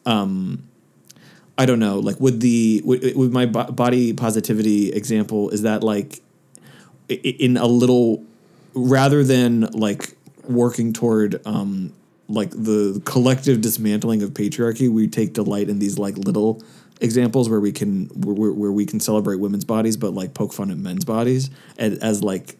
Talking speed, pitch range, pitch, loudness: 155 wpm, 105-125 Hz, 110 Hz, -20 LUFS